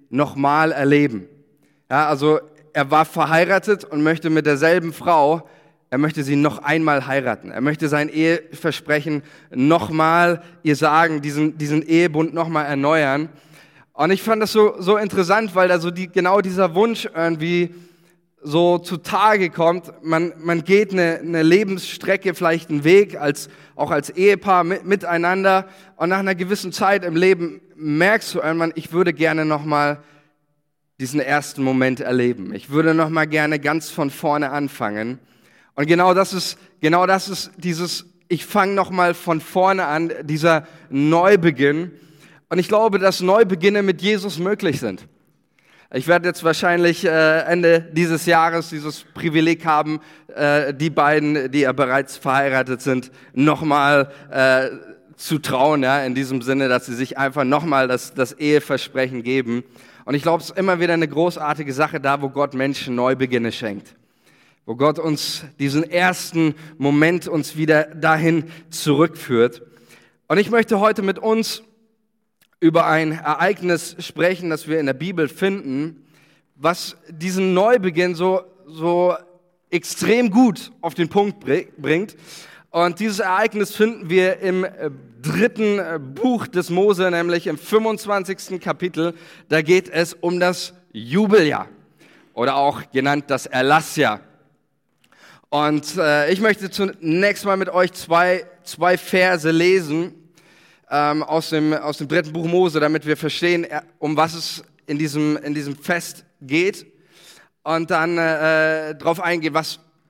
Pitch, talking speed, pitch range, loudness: 165 Hz, 145 wpm, 150-180 Hz, -19 LUFS